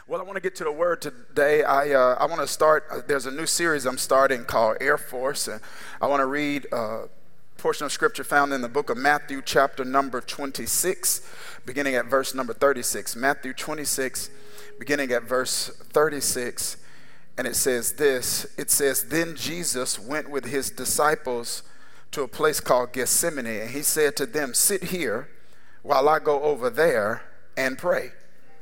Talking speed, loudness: 180 wpm, -24 LUFS